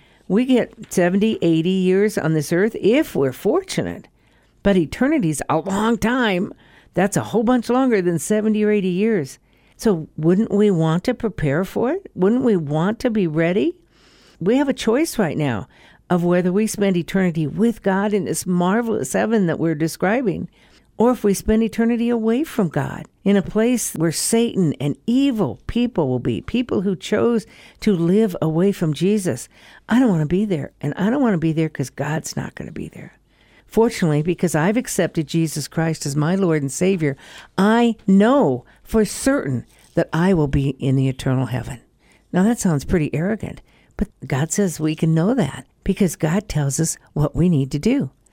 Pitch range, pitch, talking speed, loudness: 160-220 Hz, 185 Hz, 185 wpm, -20 LUFS